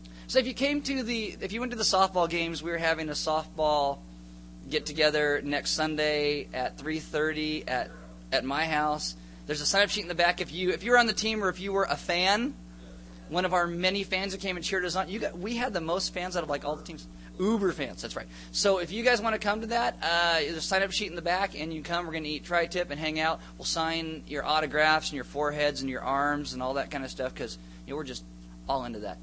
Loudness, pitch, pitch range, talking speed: -29 LUFS, 160 Hz, 145-190 Hz, 270 wpm